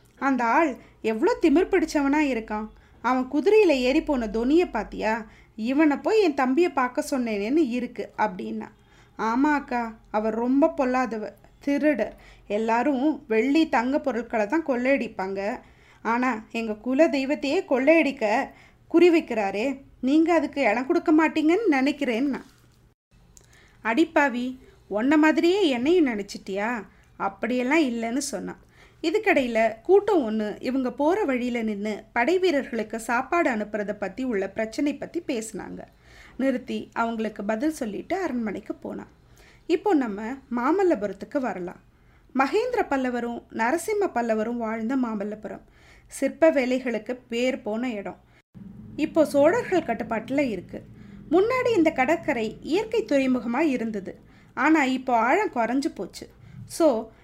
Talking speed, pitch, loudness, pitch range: 110 wpm, 260 Hz, -24 LUFS, 225-315 Hz